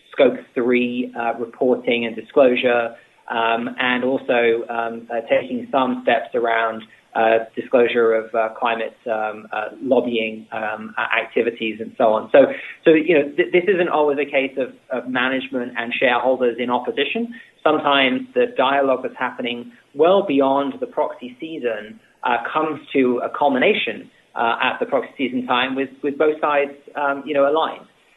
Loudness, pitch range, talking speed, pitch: -20 LUFS, 115-140 Hz, 160 wpm, 125 Hz